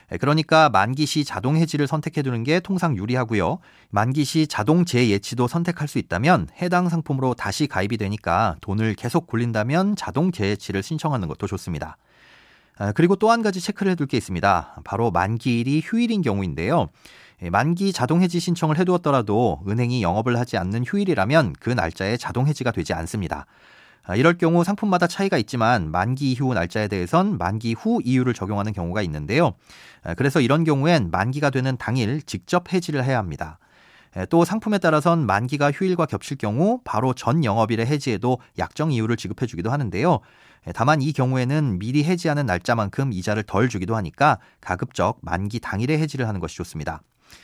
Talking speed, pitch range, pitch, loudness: 390 characters per minute, 105-160 Hz, 125 Hz, -22 LUFS